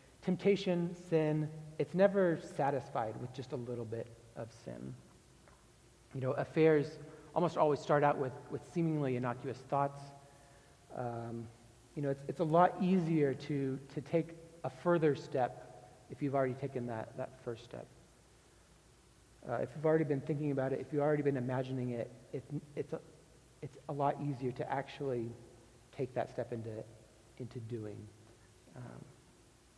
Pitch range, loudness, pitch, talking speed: 120-155 Hz, -36 LUFS, 140 Hz, 155 wpm